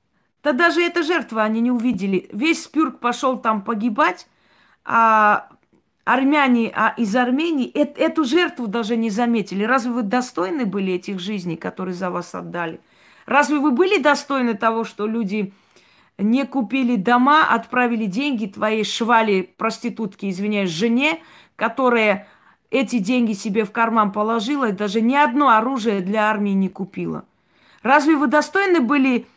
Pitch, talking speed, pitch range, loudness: 235 Hz, 140 wpm, 215-270 Hz, -19 LUFS